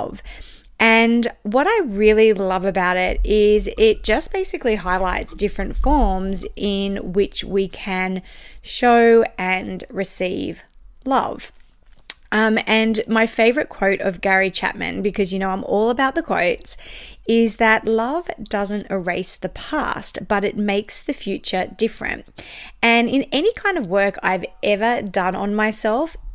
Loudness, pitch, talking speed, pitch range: -19 LUFS, 210 Hz, 140 wpm, 195-230 Hz